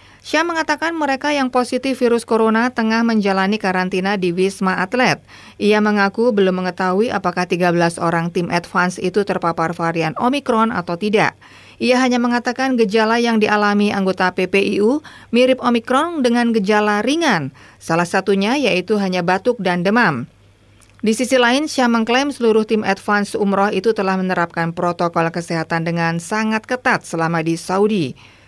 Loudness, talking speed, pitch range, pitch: -17 LUFS, 145 wpm, 180-240 Hz, 205 Hz